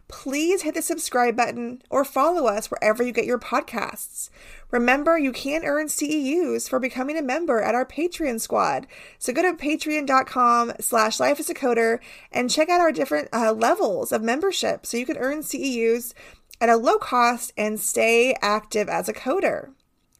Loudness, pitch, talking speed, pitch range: -22 LUFS, 255 Hz, 175 wpm, 235-305 Hz